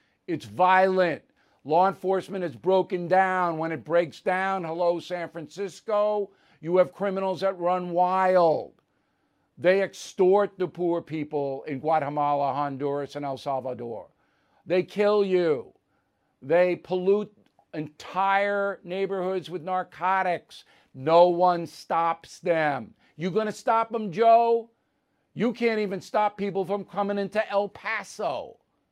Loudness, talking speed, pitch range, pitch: -25 LUFS, 120 wpm, 165-195 Hz, 185 Hz